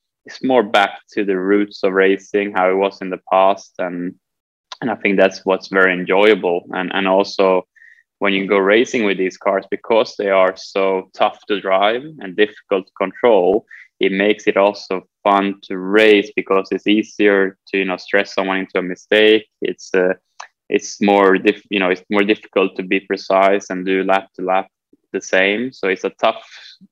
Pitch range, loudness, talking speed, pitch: 95-100 Hz, -17 LUFS, 190 wpm, 95 Hz